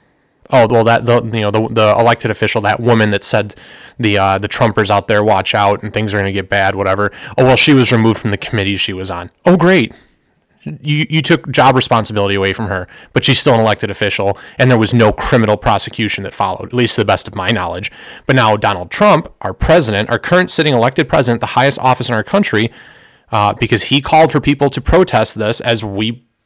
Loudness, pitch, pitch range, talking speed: -13 LUFS, 115 Hz, 105-130 Hz, 230 wpm